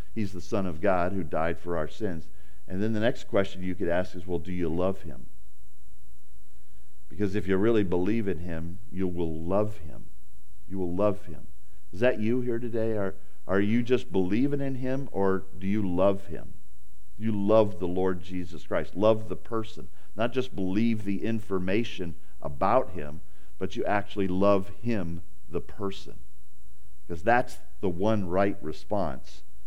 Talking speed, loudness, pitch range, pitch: 170 wpm, -29 LUFS, 85-105 Hz, 95 Hz